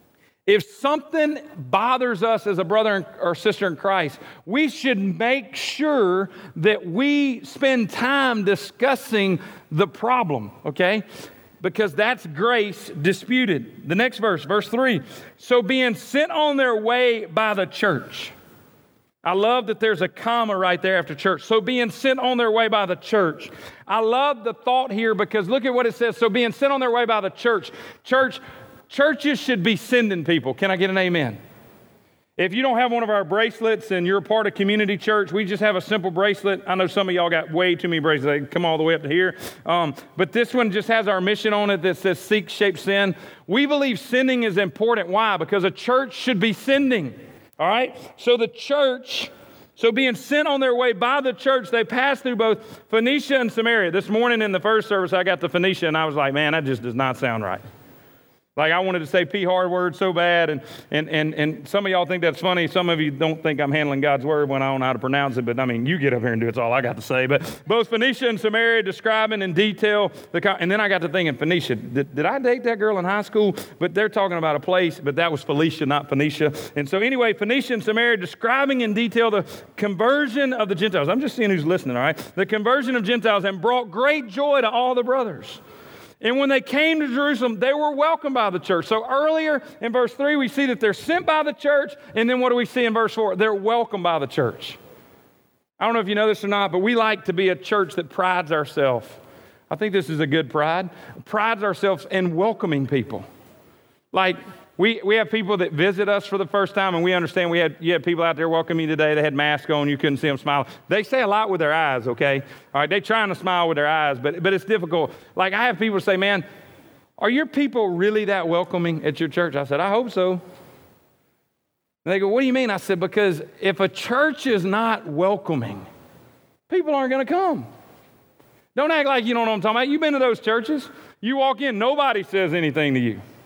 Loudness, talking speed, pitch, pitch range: -21 LUFS, 230 wpm, 205 Hz, 175-240 Hz